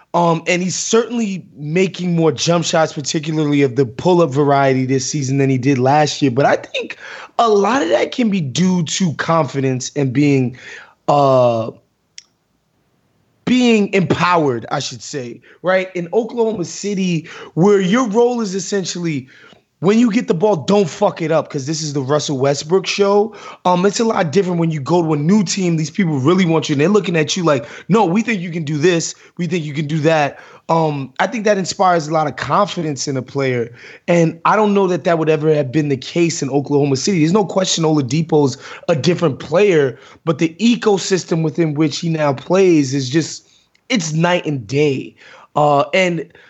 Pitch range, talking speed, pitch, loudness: 145-190 Hz, 195 wpm, 165 Hz, -16 LUFS